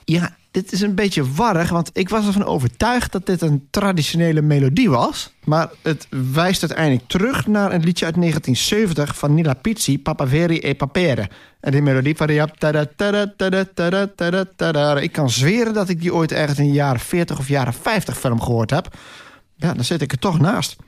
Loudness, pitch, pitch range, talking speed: -18 LUFS, 165 Hz, 145-190 Hz, 185 wpm